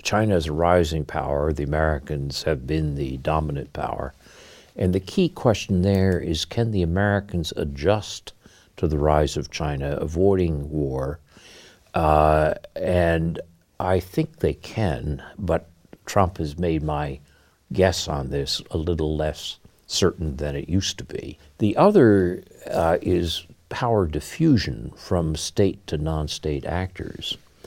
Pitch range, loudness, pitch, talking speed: 75-95 Hz, -23 LUFS, 80 Hz, 140 wpm